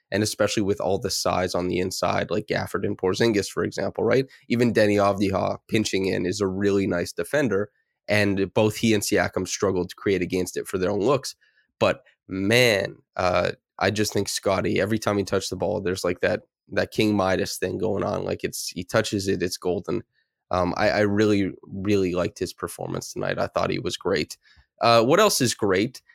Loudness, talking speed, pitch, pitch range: -24 LUFS, 200 wpm, 100 Hz, 95-105 Hz